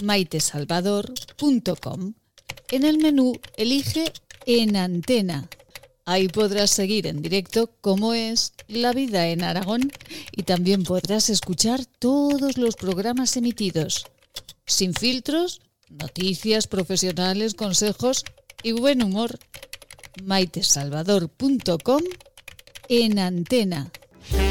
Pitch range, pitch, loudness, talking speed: 185-245 Hz, 210 Hz, -22 LUFS, 90 wpm